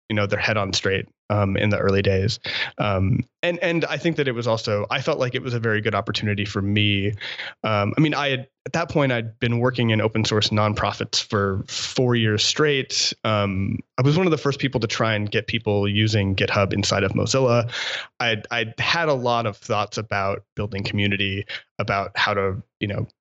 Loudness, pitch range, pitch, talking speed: -22 LUFS, 100-125 Hz, 110 Hz, 215 wpm